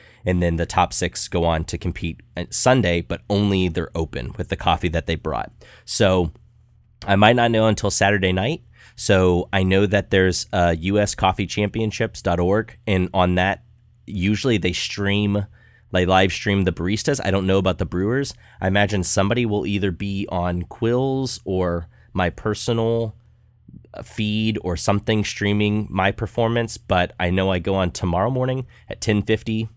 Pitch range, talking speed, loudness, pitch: 90-110 Hz, 160 wpm, -21 LUFS, 100 Hz